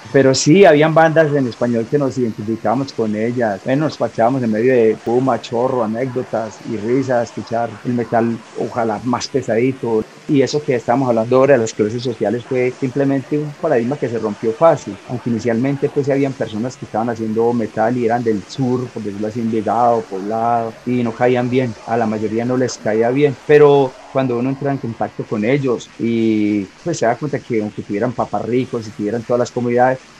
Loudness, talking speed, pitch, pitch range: -17 LUFS, 195 wpm, 120 Hz, 110-130 Hz